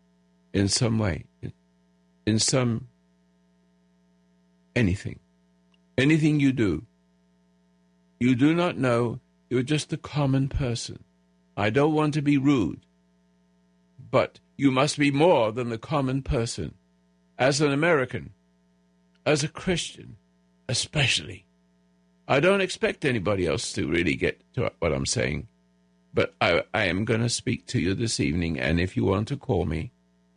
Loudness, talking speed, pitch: -25 LUFS, 140 wpm, 90 Hz